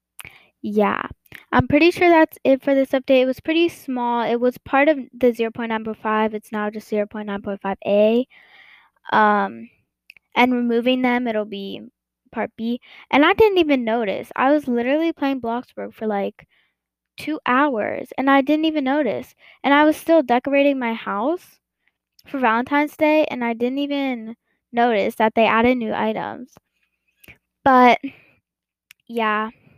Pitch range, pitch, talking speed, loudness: 225-280 Hz, 245 Hz, 145 wpm, -19 LUFS